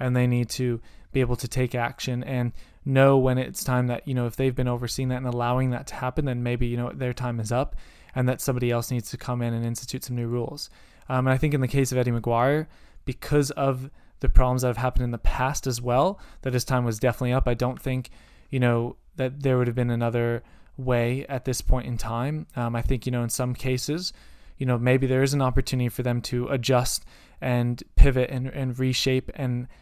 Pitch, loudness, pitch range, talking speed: 125 Hz, -26 LUFS, 120-130 Hz, 235 wpm